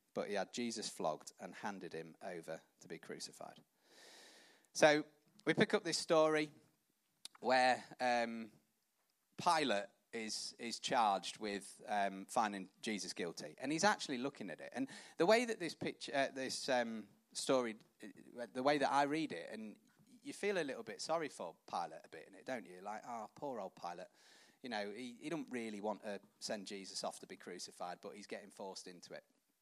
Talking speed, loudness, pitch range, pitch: 185 wpm, -40 LUFS, 105-155 Hz, 125 Hz